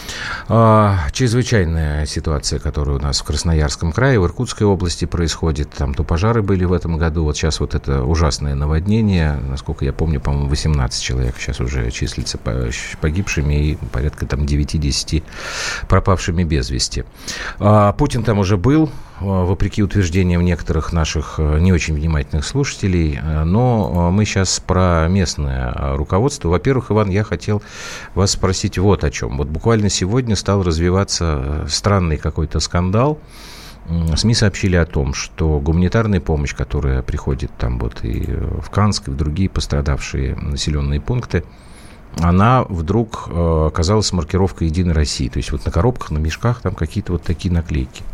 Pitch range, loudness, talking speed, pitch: 75-100 Hz, -18 LUFS, 140 wpm, 85 Hz